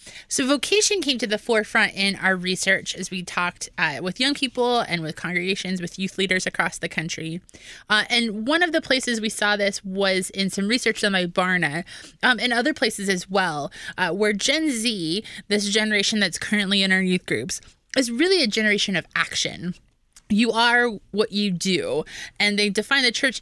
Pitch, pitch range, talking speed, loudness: 205 Hz, 185-235 Hz, 190 wpm, -22 LUFS